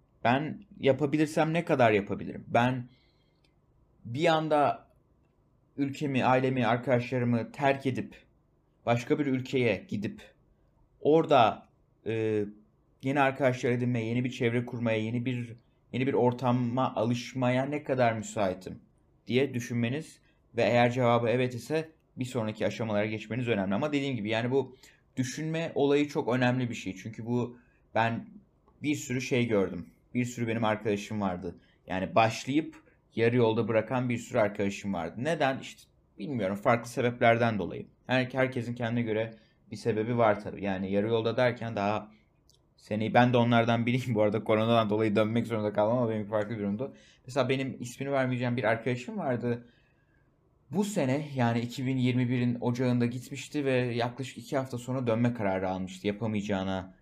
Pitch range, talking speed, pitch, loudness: 110-130 Hz, 145 wpm, 120 Hz, -29 LUFS